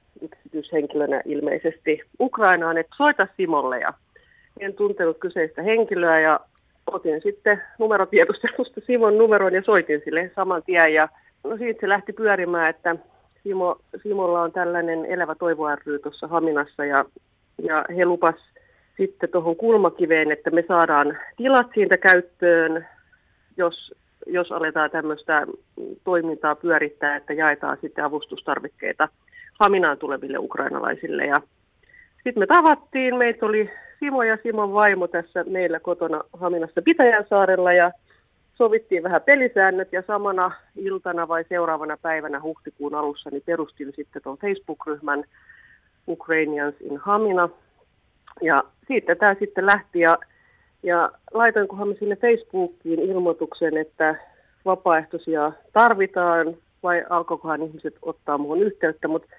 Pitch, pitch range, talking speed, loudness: 175 Hz, 160-205 Hz, 120 wpm, -21 LUFS